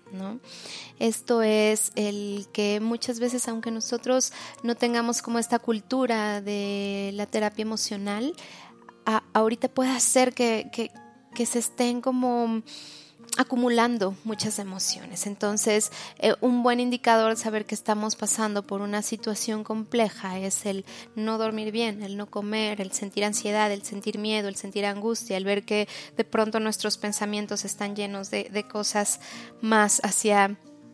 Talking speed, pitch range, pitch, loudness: 145 wpm, 205-235 Hz, 215 Hz, -26 LUFS